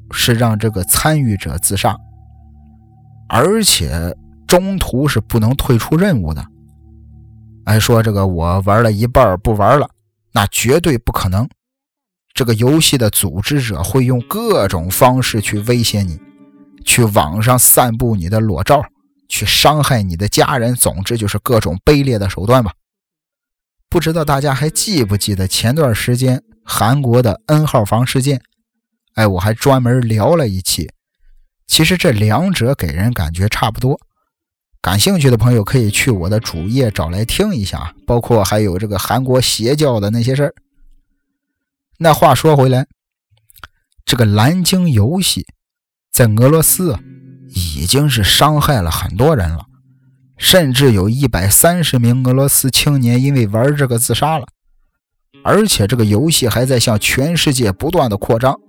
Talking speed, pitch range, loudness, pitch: 230 characters per minute, 105-140 Hz, -13 LUFS, 120 Hz